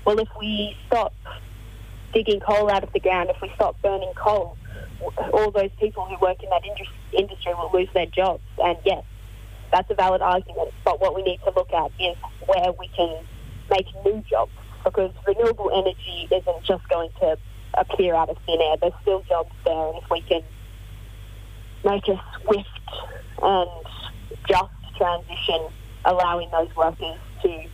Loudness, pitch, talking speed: -23 LUFS, 180 Hz, 165 wpm